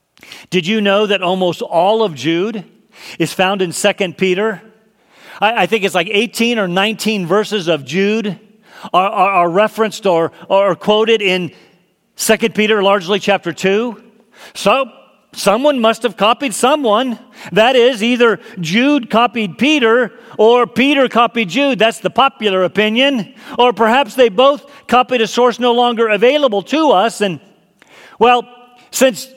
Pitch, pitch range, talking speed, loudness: 220 Hz, 200-245 Hz, 145 wpm, -14 LUFS